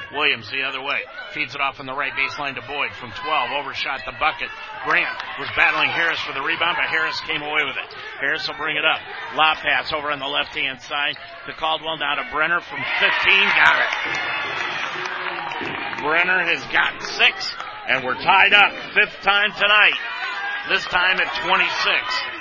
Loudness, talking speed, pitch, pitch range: -19 LUFS, 180 wpm, 155 Hz, 145-200 Hz